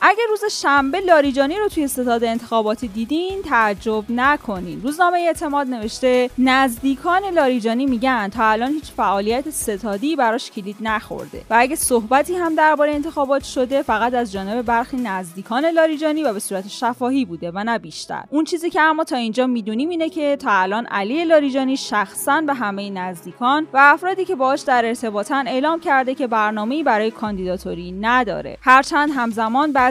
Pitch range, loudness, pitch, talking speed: 225-295 Hz, -19 LUFS, 255 Hz, 160 wpm